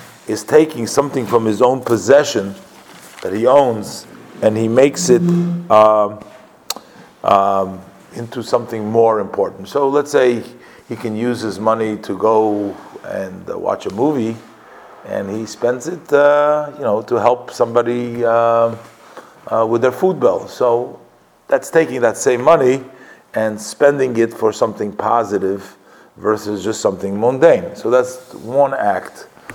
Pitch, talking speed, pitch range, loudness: 120 Hz, 145 wpm, 110-135 Hz, -16 LUFS